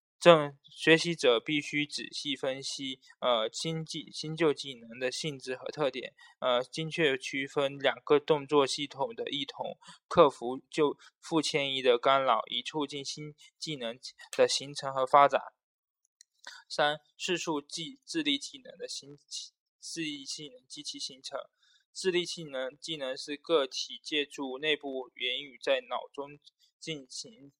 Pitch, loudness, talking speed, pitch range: 150 Hz, -31 LUFS, 210 characters per minute, 135-175 Hz